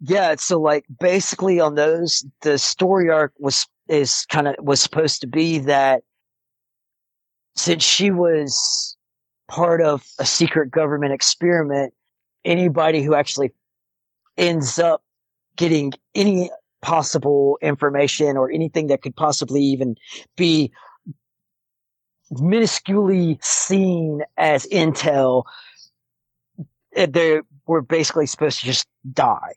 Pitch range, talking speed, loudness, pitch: 140-170 Hz, 110 wpm, -19 LUFS, 150 Hz